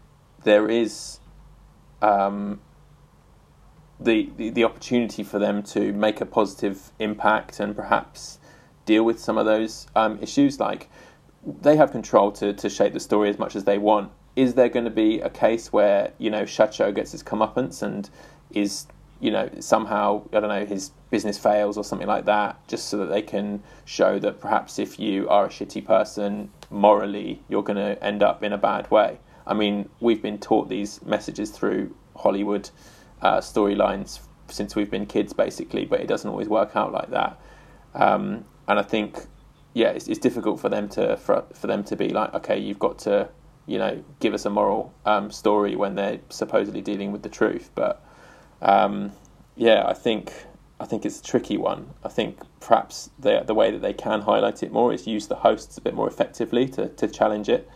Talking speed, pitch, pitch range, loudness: 190 wpm, 105 Hz, 100-115 Hz, -23 LUFS